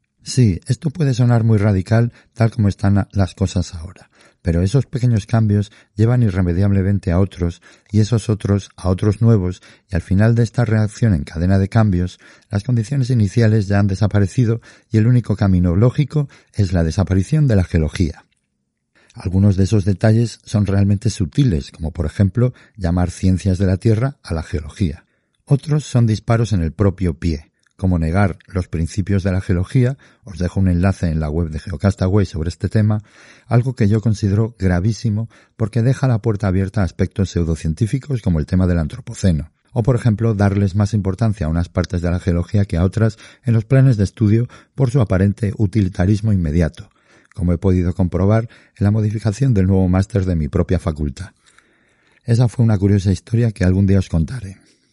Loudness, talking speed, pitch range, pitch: -18 LUFS, 180 wpm, 90-115 Hz, 100 Hz